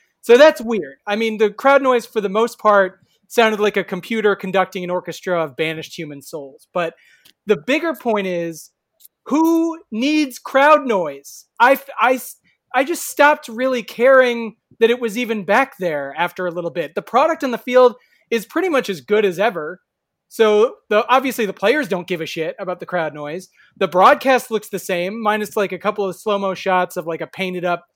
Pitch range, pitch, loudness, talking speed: 180-250 Hz, 210 Hz, -18 LUFS, 195 wpm